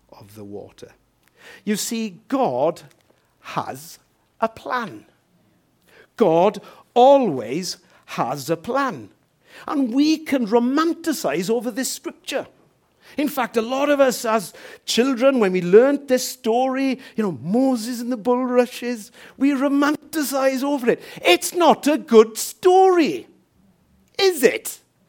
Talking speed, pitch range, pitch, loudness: 120 wpm, 230-285 Hz, 255 Hz, -20 LUFS